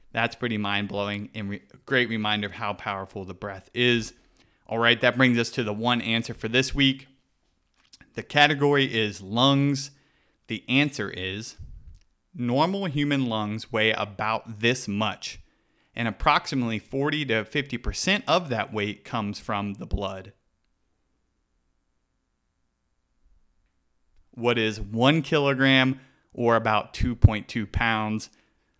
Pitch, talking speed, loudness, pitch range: 110 Hz, 125 wpm, -25 LUFS, 100-125 Hz